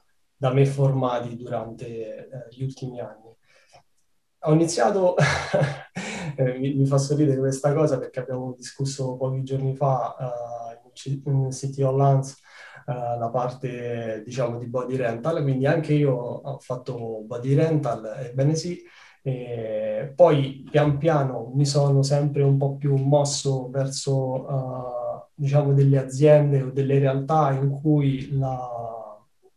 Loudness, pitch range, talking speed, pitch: -23 LUFS, 125-145 Hz, 135 wpm, 135 Hz